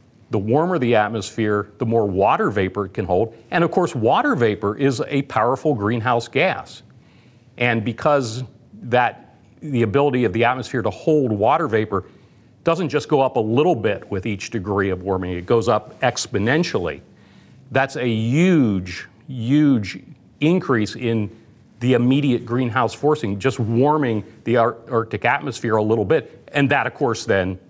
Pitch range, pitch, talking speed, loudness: 110-135 Hz, 120 Hz, 160 wpm, -20 LUFS